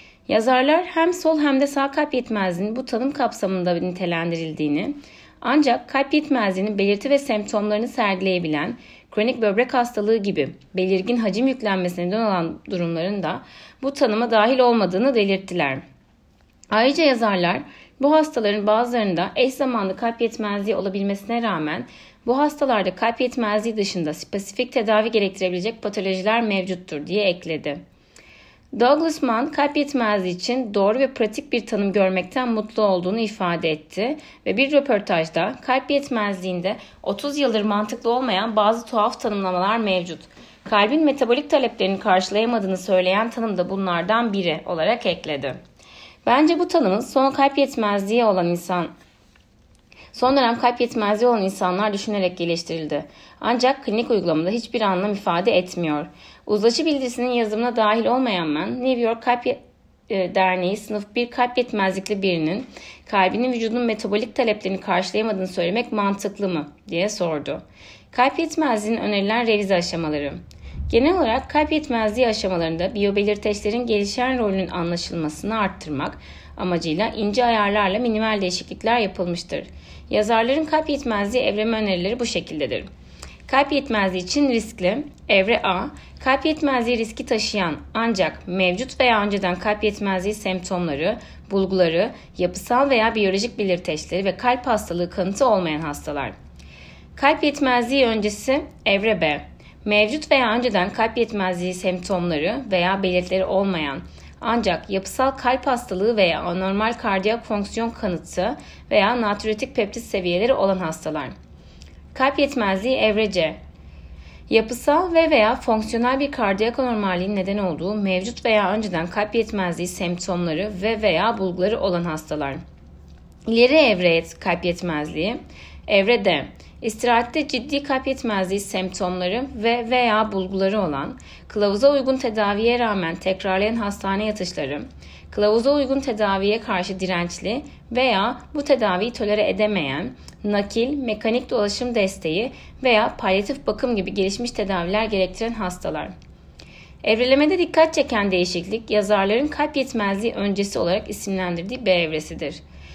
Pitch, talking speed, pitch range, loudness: 210 Hz, 120 wpm, 185-245 Hz, -21 LUFS